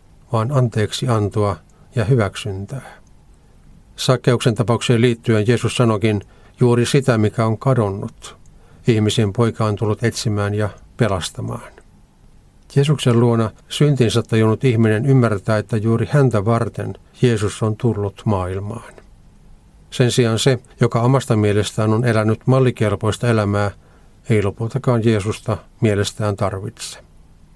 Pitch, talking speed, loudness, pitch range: 110 Hz, 110 wpm, -18 LUFS, 105-120 Hz